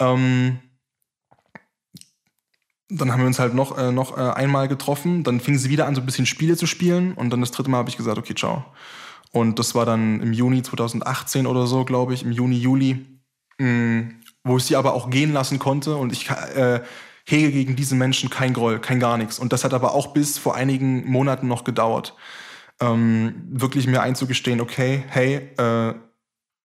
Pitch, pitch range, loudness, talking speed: 130 Hz, 120-135 Hz, -21 LUFS, 185 wpm